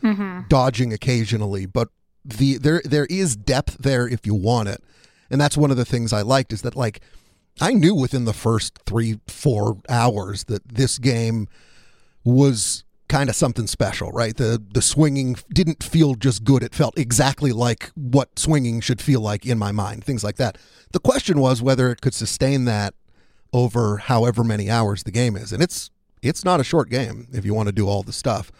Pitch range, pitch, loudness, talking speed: 110-135 Hz, 120 Hz, -20 LUFS, 195 wpm